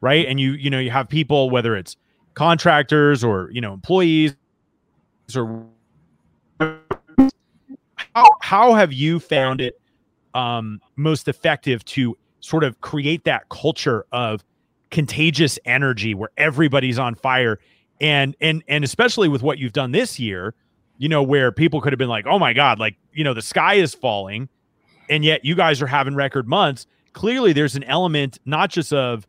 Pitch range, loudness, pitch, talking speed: 120-155 Hz, -18 LUFS, 140 Hz, 165 wpm